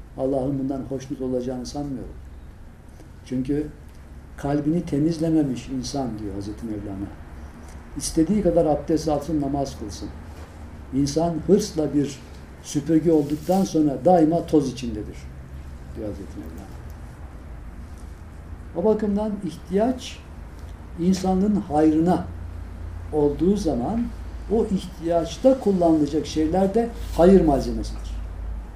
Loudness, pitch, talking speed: -23 LUFS, 135 Hz, 90 wpm